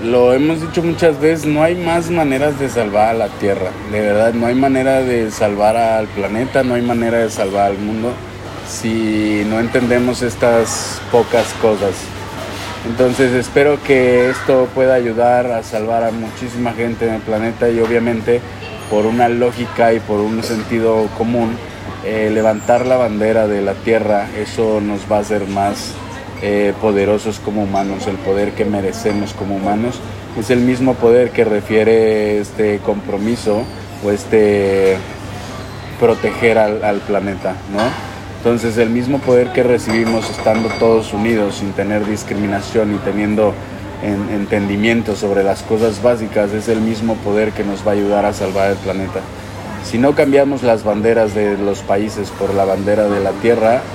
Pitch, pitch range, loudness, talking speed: 110 Hz, 100-120 Hz, -15 LUFS, 160 wpm